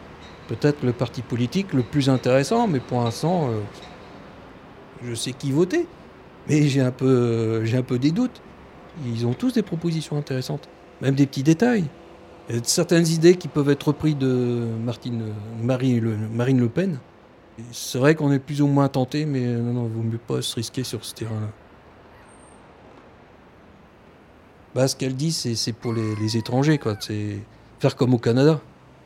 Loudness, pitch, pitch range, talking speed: -23 LUFS, 130 Hz, 115-150 Hz, 180 wpm